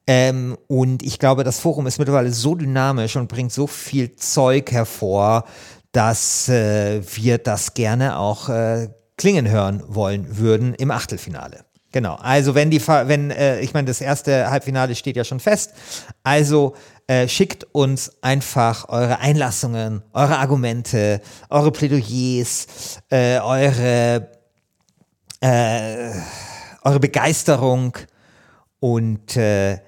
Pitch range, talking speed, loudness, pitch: 115-140 Hz, 125 wpm, -19 LUFS, 125 Hz